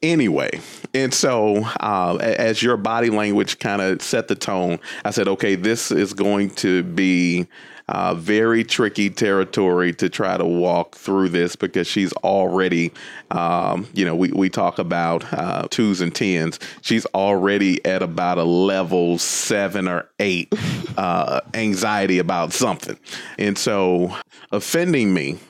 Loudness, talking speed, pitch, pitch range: -20 LUFS, 145 wpm, 95 Hz, 90-105 Hz